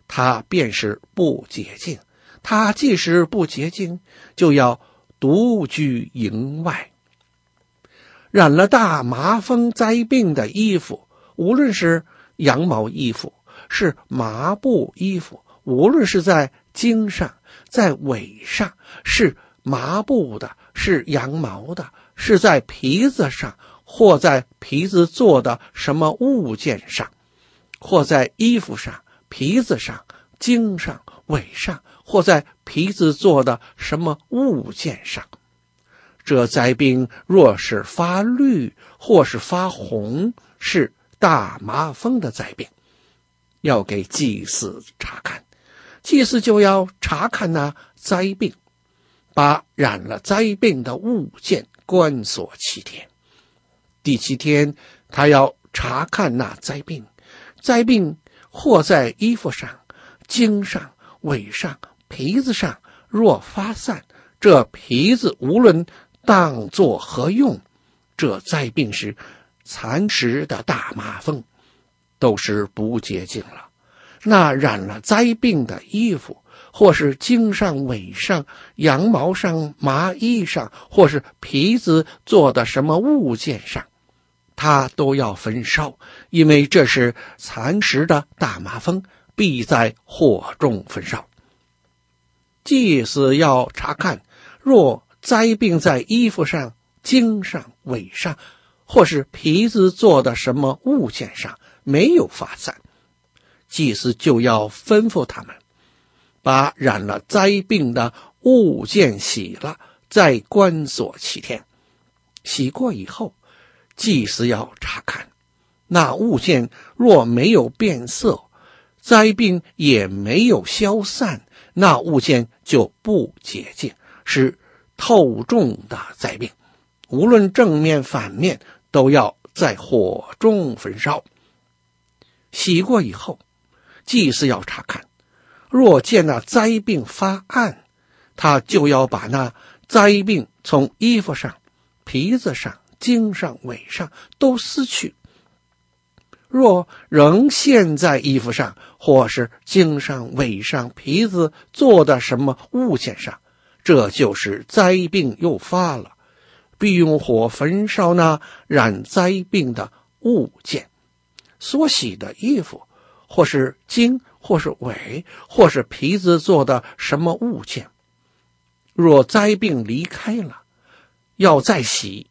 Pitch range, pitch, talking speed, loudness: 130-215 Hz, 170 Hz, 160 characters per minute, -17 LUFS